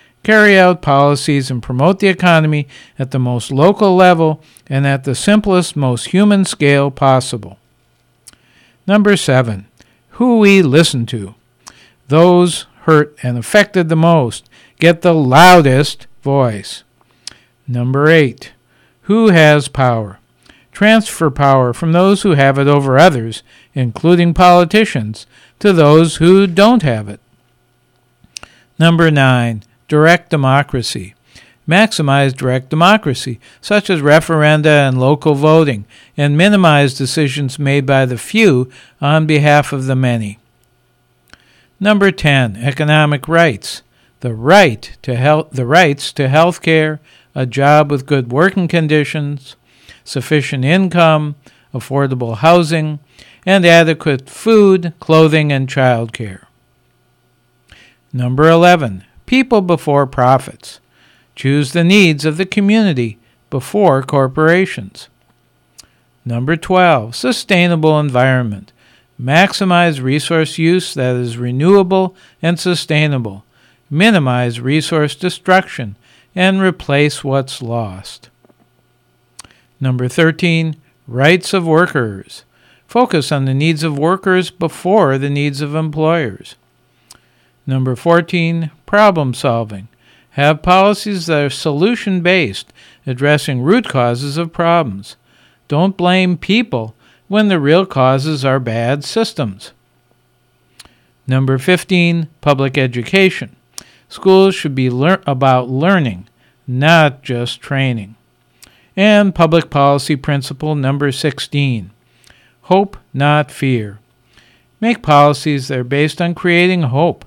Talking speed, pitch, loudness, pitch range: 110 wpm, 145 Hz, -12 LUFS, 125-170 Hz